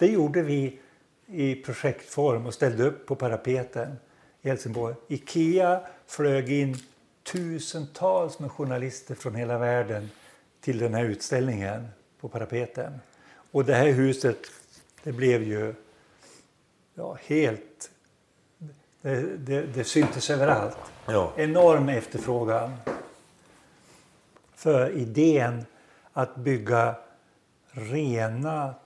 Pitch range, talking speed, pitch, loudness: 120-150 Hz, 100 wpm, 135 Hz, -27 LUFS